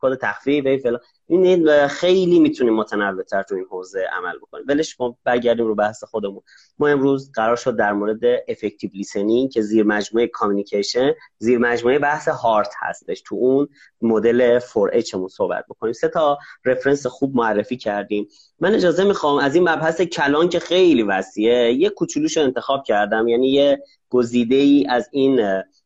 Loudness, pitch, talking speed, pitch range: -19 LUFS, 130 Hz, 160 wpm, 115-155 Hz